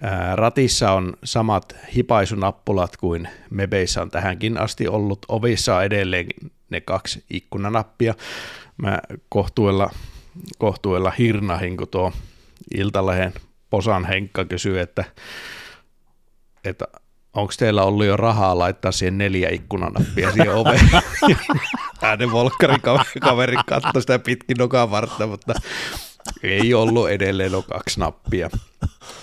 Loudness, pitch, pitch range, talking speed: -20 LUFS, 100 Hz, 95-115 Hz, 110 wpm